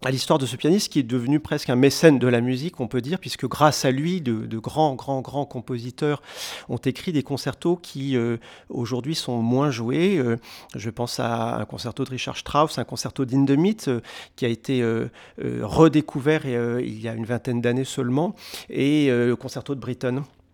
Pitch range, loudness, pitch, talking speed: 120-145 Hz, -23 LUFS, 130 Hz, 205 wpm